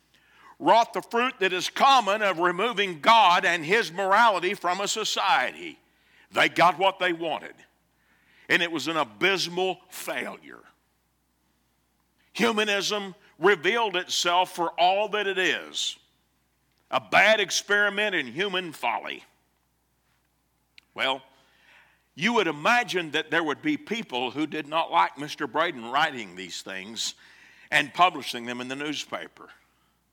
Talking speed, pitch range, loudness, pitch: 125 wpm, 145-205 Hz, -24 LUFS, 180 Hz